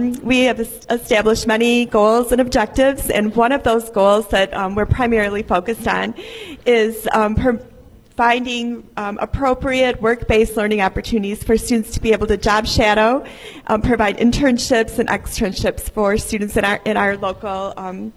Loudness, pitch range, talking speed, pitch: -17 LUFS, 210-240 Hz, 160 wpm, 225 Hz